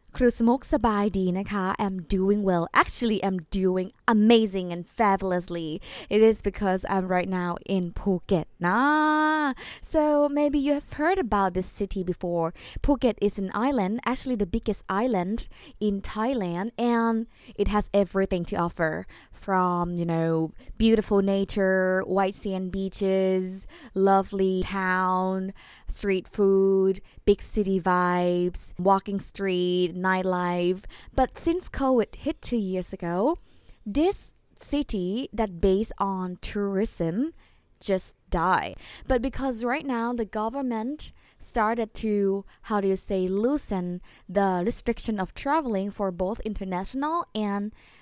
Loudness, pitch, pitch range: -26 LUFS, 200 Hz, 185-235 Hz